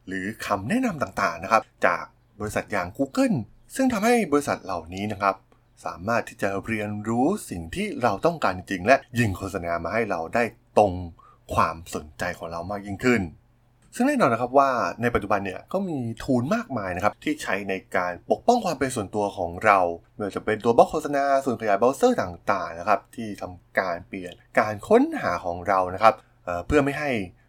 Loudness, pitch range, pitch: -24 LUFS, 95-135 Hz, 110 Hz